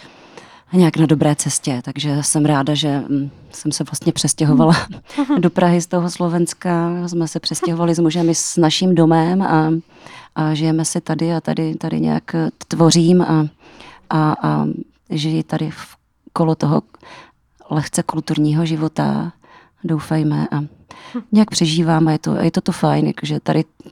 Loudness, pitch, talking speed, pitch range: -17 LUFS, 160 Hz, 150 wpm, 150-170 Hz